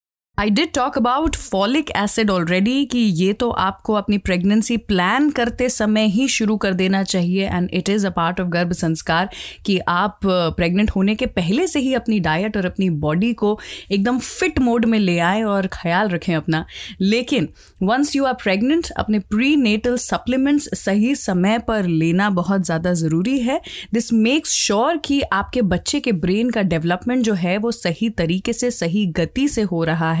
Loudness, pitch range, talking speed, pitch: -18 LUFS, 180-240 Hz, 185 wpm, 210 Hz